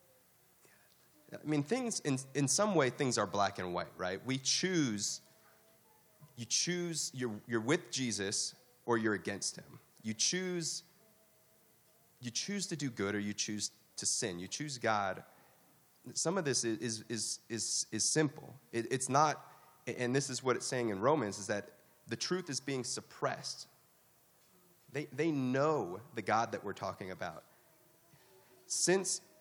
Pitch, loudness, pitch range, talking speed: 130 Hz, -35 LUFS, 110-155 Hz, 155 wpm